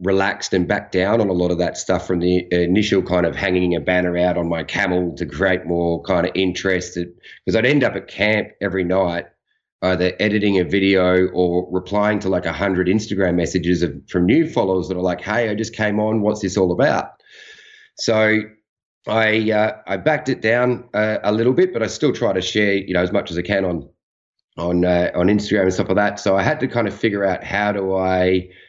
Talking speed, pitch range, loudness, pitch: 225 wpm, 90-105 Hz, -19 LUFS, 95 Hz